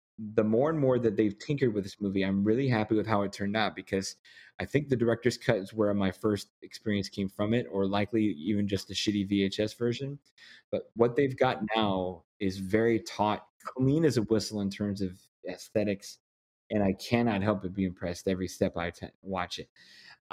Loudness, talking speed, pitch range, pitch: -30 LUFS, 200 wpm, 95-115 Hz, 105 Hz